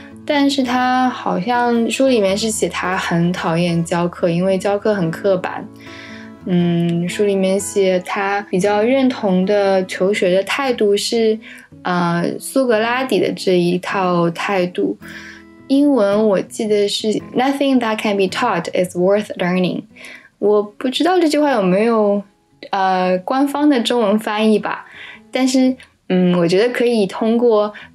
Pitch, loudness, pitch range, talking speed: 205 Hz, -17 LUFS, 185-245 Hz, 265 characters per minute